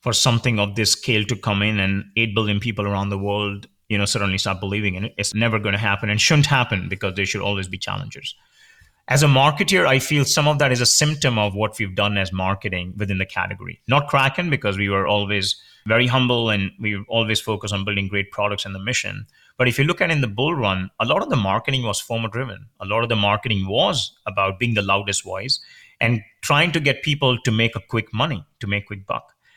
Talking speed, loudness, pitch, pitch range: 235 wpm, -20 LUFS, 110 Hz, 100-125 Hz